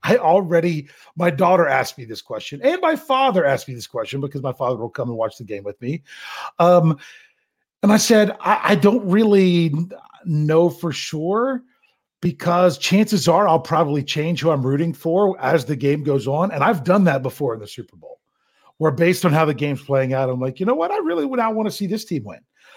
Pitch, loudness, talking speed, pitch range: 170 Hz, -19 LUFS, 220 wpm, 140-200 Hz